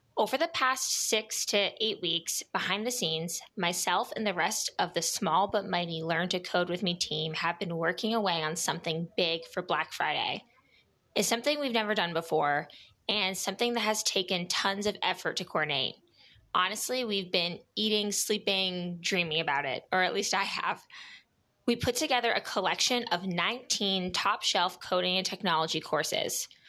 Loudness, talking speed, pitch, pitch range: -29 LUFS, 175 wpm, 190 Hz, 170-215 Hz